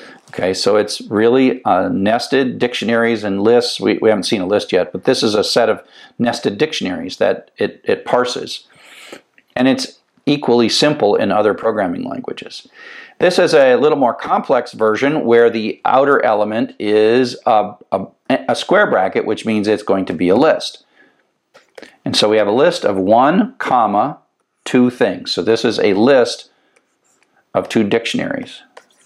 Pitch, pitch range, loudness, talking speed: 115 Hz, 110-140 Hz, -15 LUFS, 165 wpm